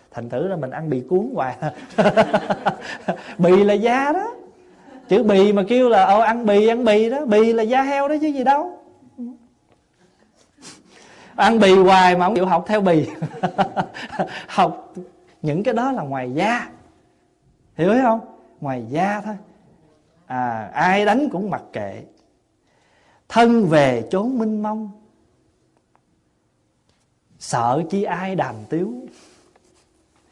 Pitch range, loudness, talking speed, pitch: 175-235 Hz, -19 LUFS, 135 wpm, 205 Hz